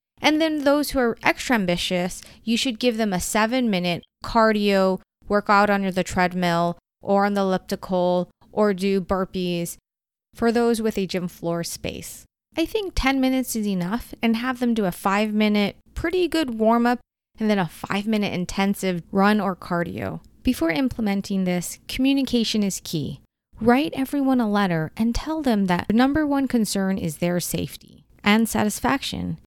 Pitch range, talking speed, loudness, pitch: 185-245 Hz, 160 wpm, -22 LUFS, 210 Hz